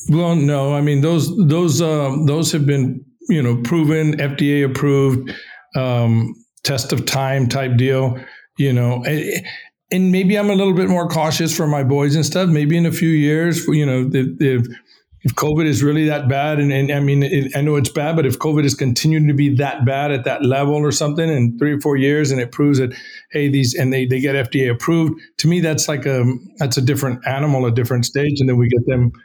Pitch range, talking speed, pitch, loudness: 130-155 Hz, 220 wpm, 145 Hz, -17 LUFS